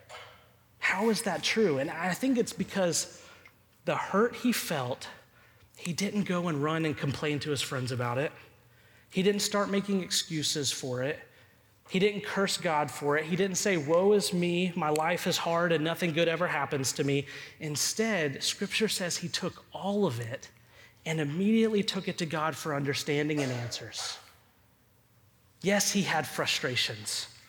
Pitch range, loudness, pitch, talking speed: 140-195 Hz, -29 LUFS, 160 Hz, 170 wpm